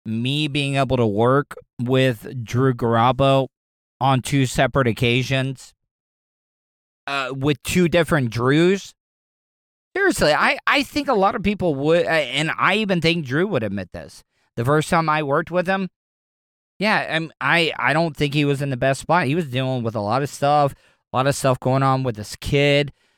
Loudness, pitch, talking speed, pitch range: -20 LUFS, 140 Hz, 180 wpm, 130-165 Hz